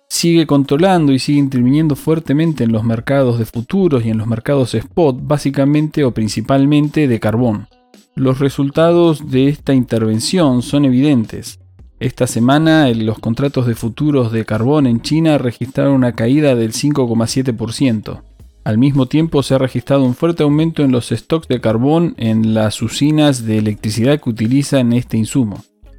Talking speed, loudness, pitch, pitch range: 150 wpm, -14 LUFS, 130 Hz, 115-145 Hz